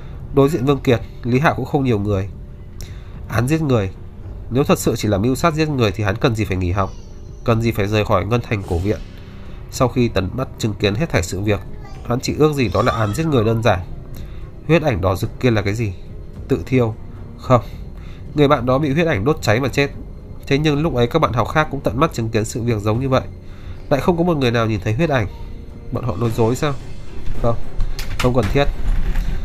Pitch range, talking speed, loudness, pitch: 95-130 Hz, 240 wpm, -19 LUFS, 115 Hz